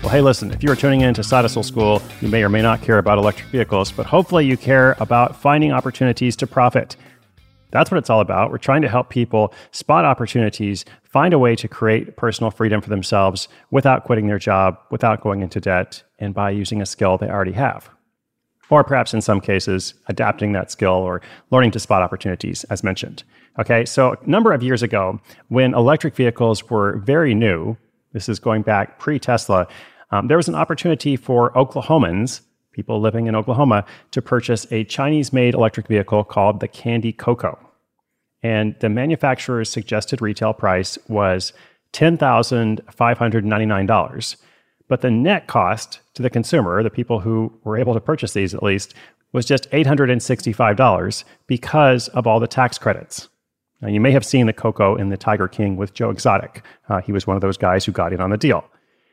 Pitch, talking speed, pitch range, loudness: 115 Hz, 185 wpm, 105-130 Hz, -18 LUFS